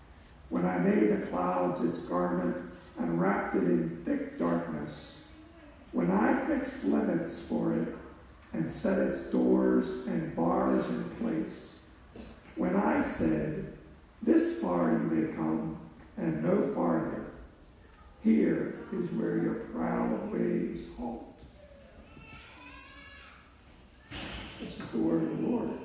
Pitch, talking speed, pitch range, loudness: 80 Hz, 120 wpm, 65-85 Hz, -31 LUFS